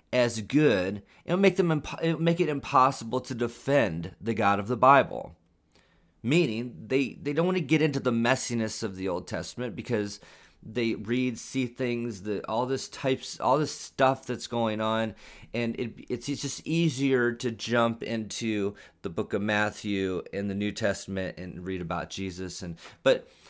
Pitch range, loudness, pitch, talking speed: 105-135 Hz, -28 LUFS, 120 Hz, 180 wpm